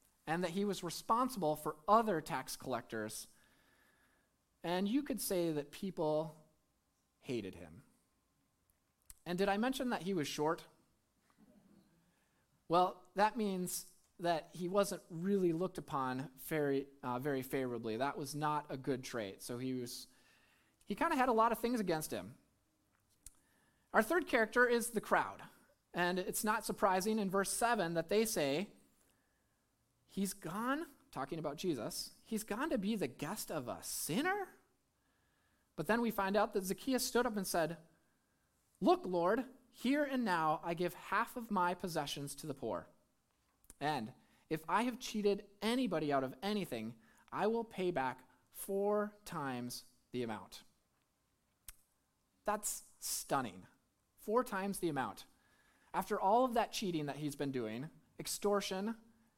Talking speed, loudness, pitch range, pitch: 145 wpm, -38 LUFS, 150-220 Hz, 180 Hz